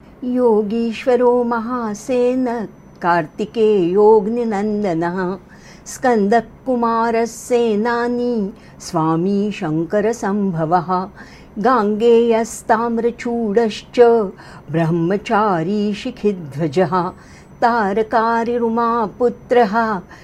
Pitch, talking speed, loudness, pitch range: 220 Hz, 35 wpm, -17 LUFS, 195-235 Hz